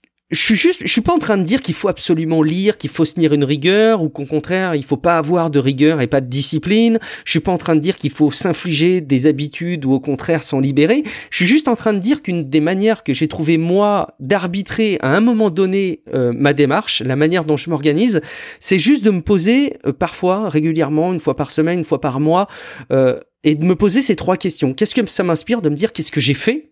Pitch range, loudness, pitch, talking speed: 150-205 Hz, -15 LUFS, 170 Hz, 250 wpm